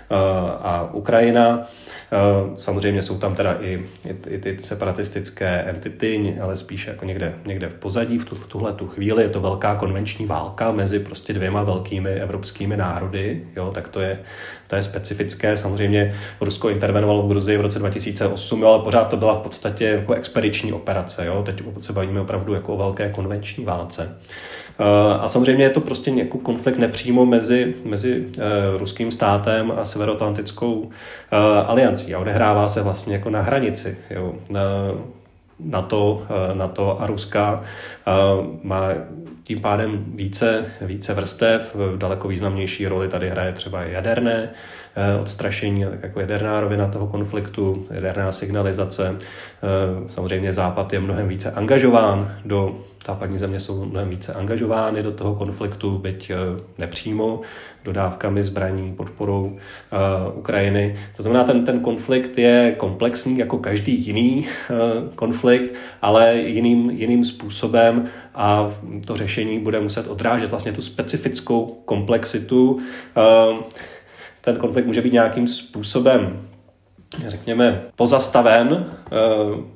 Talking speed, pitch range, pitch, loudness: 135 wpm, 95-115 Hz, 105 Hz, -20 LUFS